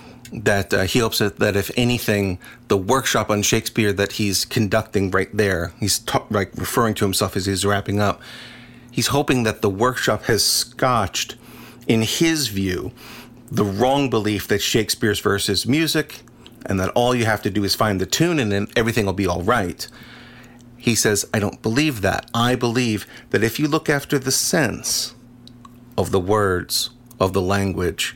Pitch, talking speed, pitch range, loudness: 115 Hz, 175 wpm, 100-120 Hz, -20 LUFS